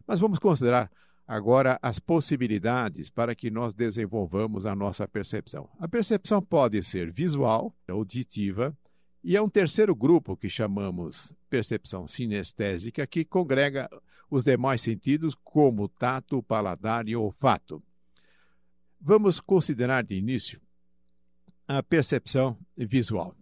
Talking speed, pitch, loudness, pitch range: 115 wpm, 120 Hz, -27 LUFS, 100-140 Hz